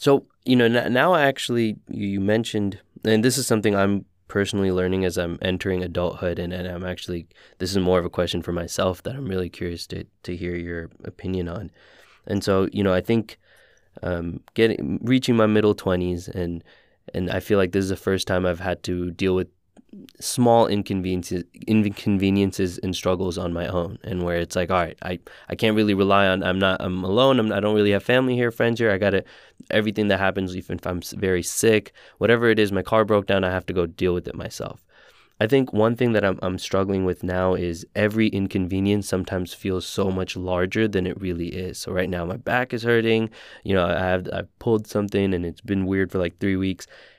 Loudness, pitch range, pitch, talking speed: -23 LUFS, 90-105 Hz, 95 Hz, 220 wpm